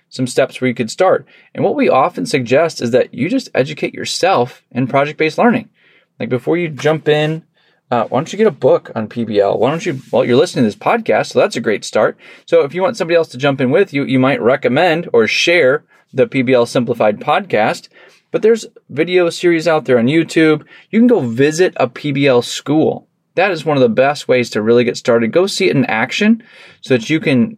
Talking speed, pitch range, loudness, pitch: 225 wpm, 125-190 Hz, -14 LUFS, 155 Hz